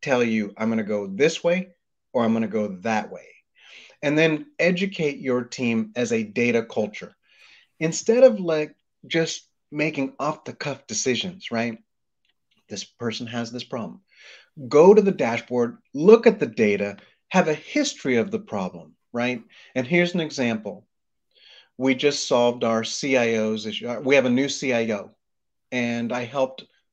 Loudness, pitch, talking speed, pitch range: -23 LUFS, 125 Hz, 160 wpm, 115-160 Hz